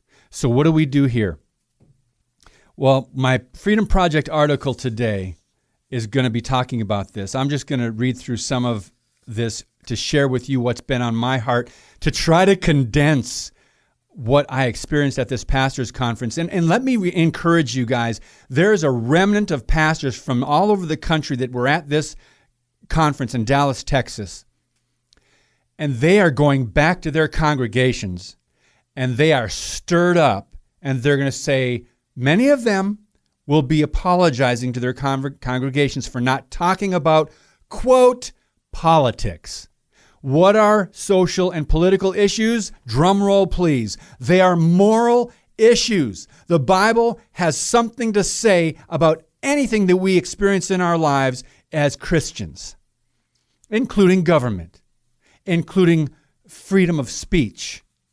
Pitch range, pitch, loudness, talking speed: 125-175 Hz, 145 Hz, -18 LUFS, 145 wpm